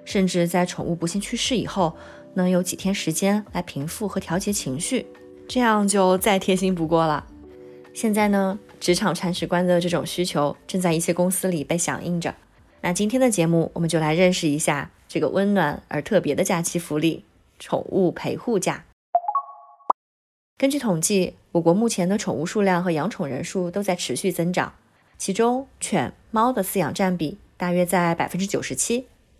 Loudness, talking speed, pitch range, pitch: -23 LUFS, 265 characters per minute, 165-195 Hz, 180 Hz